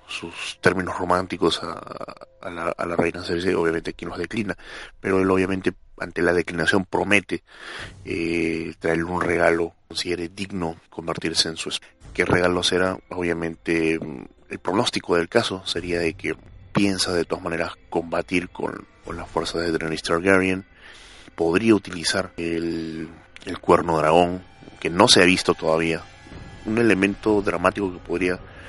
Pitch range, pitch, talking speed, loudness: 85-95 Hz, 90 Hz, 150 wpm, -23 LUFS